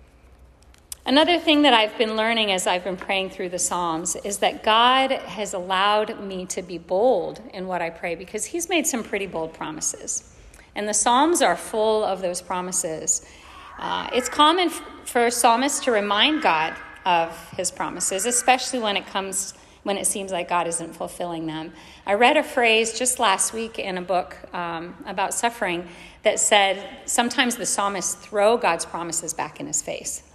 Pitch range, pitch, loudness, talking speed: 175-235 Hz, 200 Hz, -22 LUFS, 180 wpm